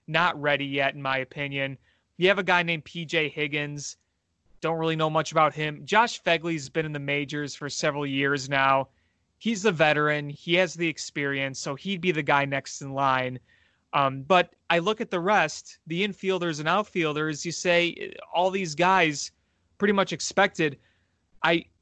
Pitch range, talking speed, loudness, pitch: 140-175 Hz, 175 wpm, -25 LUFS, 155 Hz